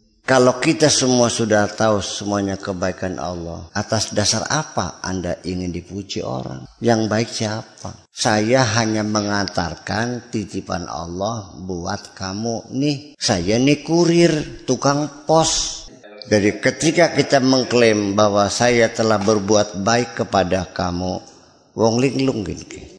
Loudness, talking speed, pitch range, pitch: -19 LUFS, 115 wpm, 95-125 Hz, 110 Hz